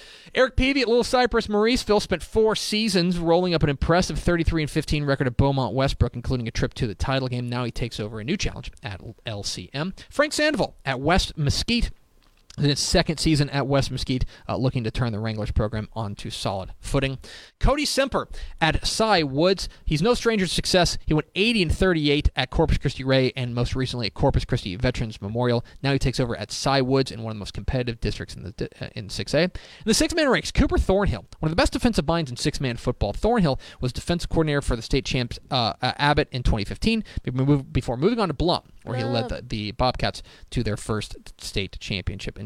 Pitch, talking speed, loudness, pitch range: 135 Hz, 210 wpm, -24 LUFS, 120-175 Hz